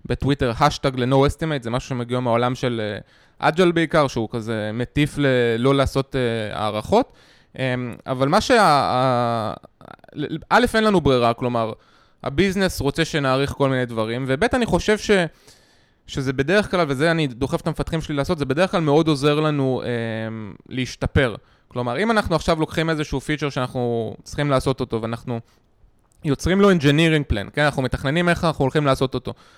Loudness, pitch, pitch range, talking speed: -21 LUFS, 135 Hz, 120-160 Hz, 160 wpm